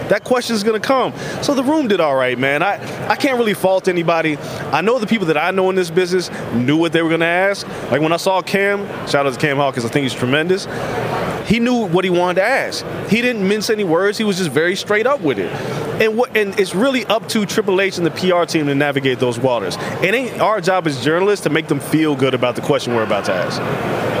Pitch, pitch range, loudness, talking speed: 185 Hz, 155-210 Hz, -17 LUFS, 255 wpm